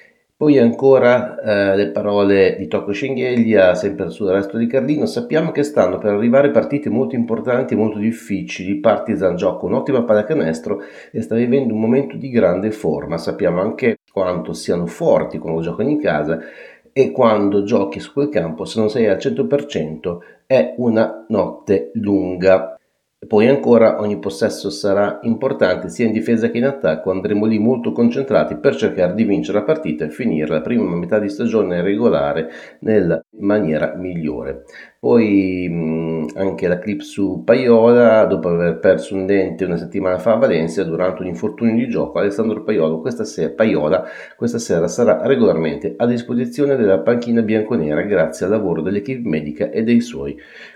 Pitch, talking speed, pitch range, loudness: 105 Hz, 160 wpm, 90-115 Hz, -17 LUFS